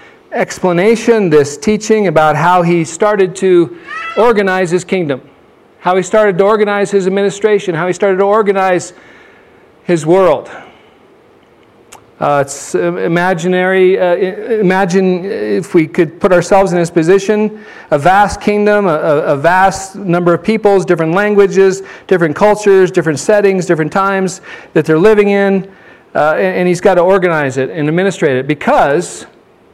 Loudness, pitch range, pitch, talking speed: -11 LUFS, 175-205 Hz, 190 Hz, 140 wpm